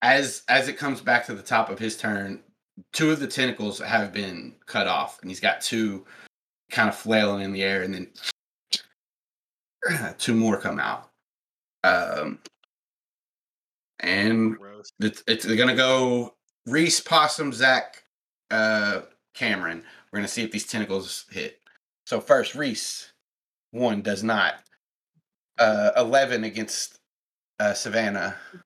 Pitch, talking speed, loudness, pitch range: 110 Hz, 140 wpm, -24 LUFS, 105-130 Hz